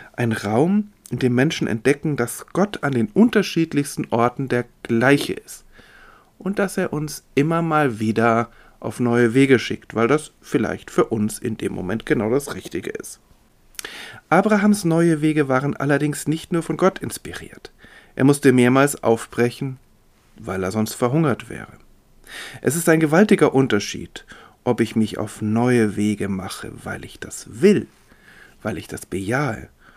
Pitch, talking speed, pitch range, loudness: 135 Hz, 155 wpm, 115-160 Hz, -20 LUFS